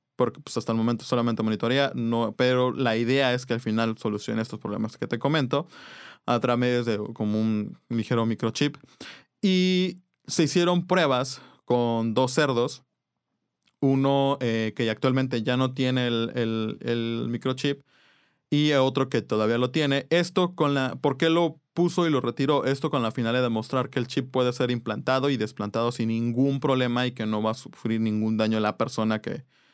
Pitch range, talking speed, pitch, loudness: 115-140 Hz, 185 wpm, 125 Hz, -25 LUFS